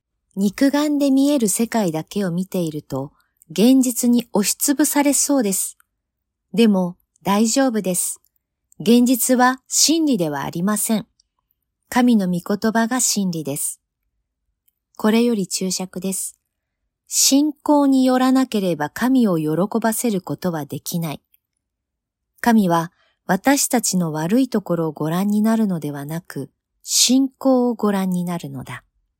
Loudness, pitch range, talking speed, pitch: -19 LUFS, 165-250 Hz, 245 characters per minute, 200 Hz